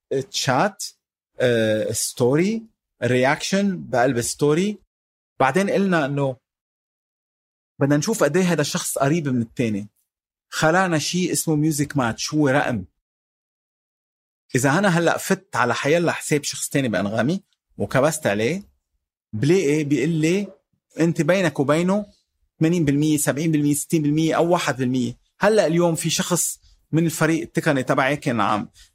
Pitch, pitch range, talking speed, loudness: 150 Hz, 125-170 Hz, 120 wpm, -21 LUFS